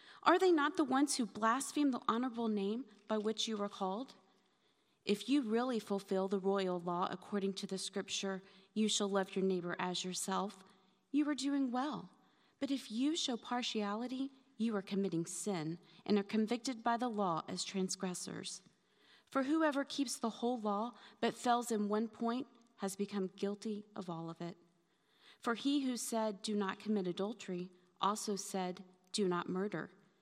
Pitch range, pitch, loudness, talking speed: 190-240 Hz, 205 Hz, -38 LUFS, 170 wpm